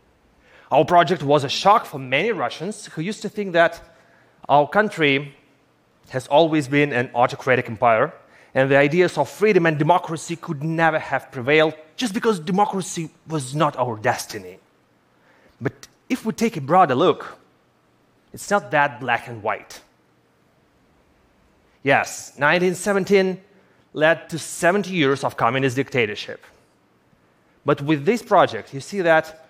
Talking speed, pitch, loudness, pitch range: 140 wpm, 160 Hz, -20 LUFS, 140-185 Hz